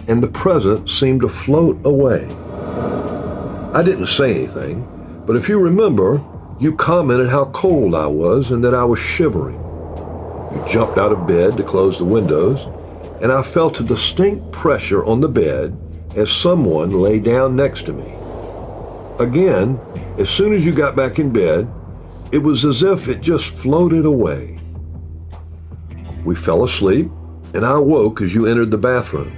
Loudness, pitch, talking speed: -16 LUFS, 115 Hz, 160 wpm